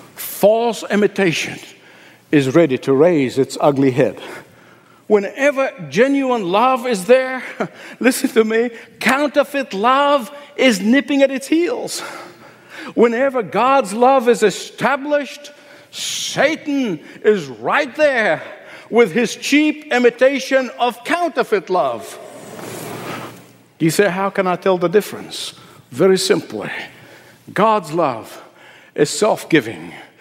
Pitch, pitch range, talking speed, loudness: 240 Hz, 195-275 Hz, 110 wpm, -17 LUFS